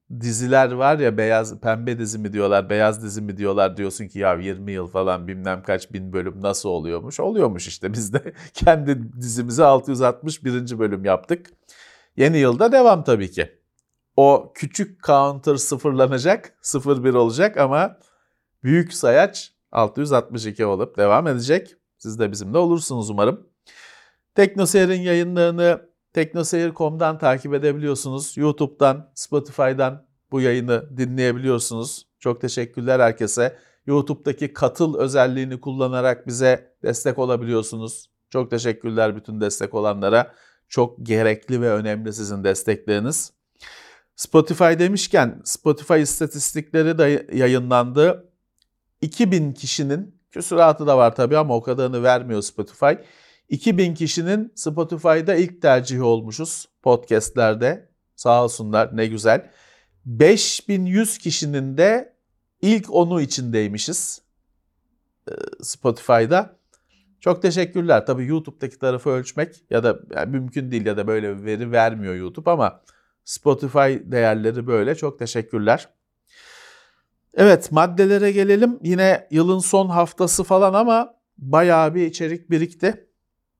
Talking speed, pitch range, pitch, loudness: 110 wpm, 115-165 Hz, 135 Hz, -20 LUFS